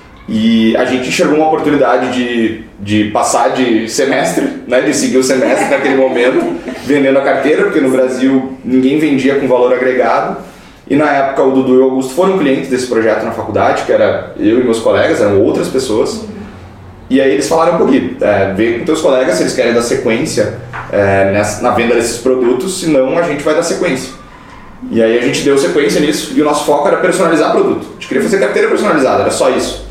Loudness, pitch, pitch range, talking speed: -12 LUFS, 130 Hz, 115-135 Hz, 205 wpm